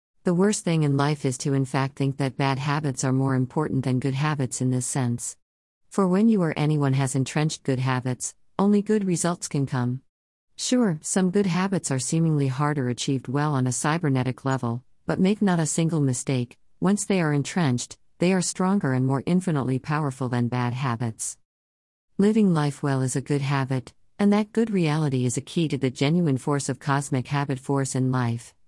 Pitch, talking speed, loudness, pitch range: 140 Hz, 195 wpm, -24 LUFS, 130-165 Hz